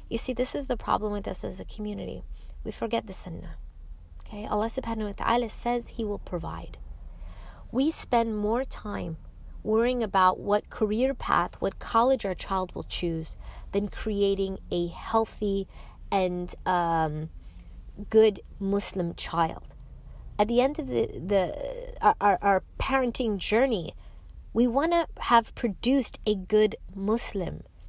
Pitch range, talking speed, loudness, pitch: 175-230 Hz, 140 wpm, -28 LUFS, 205 Hz